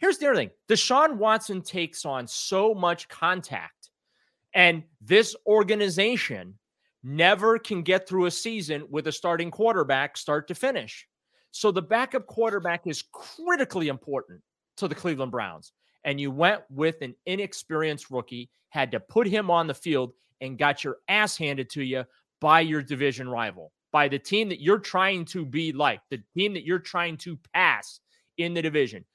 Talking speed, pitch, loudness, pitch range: 170 wpm, 170 Hz, -25 LUFS, 140-205 Hz